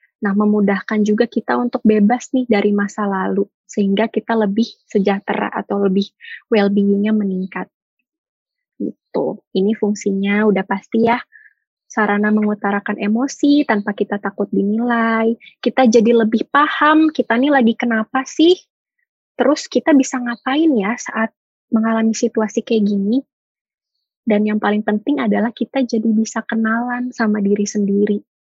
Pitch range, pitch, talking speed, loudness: 205-245 Hz, 225 Hz, 130 wpm, -17 LUFS